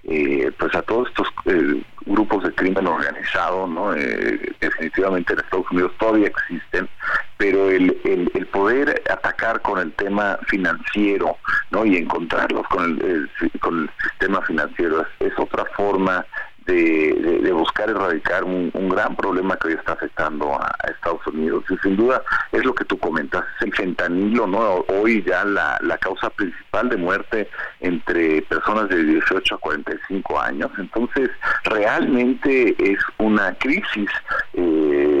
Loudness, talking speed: -20 LUFS, 155 wpm